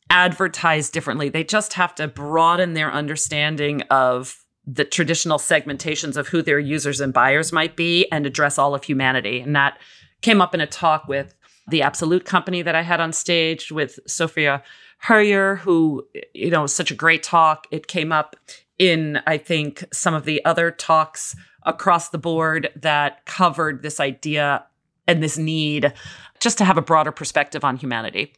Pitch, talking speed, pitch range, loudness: 155 Hz, 175 wpm, 145-170 Hz, -19 LUFS